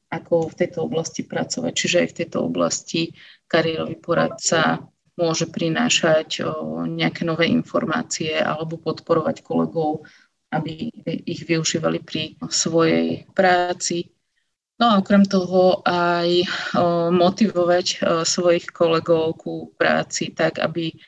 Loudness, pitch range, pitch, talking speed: -21 LUFS, 160-180 Hz, 165 Hz, 110 wpm